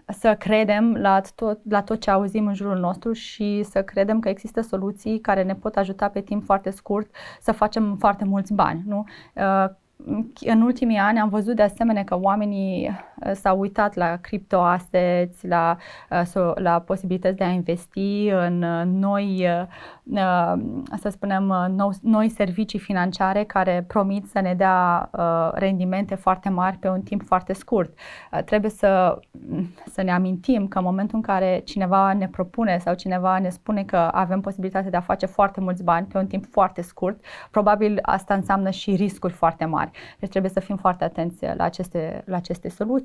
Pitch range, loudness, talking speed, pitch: 185-205 Hz, -22 LUFS, 165 wpm, 195 Hz